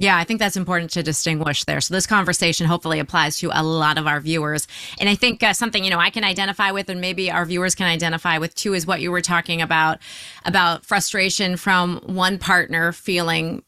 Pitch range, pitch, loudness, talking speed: 165-190 Hz, 175 Hz, -19 LUFS, 220 wpm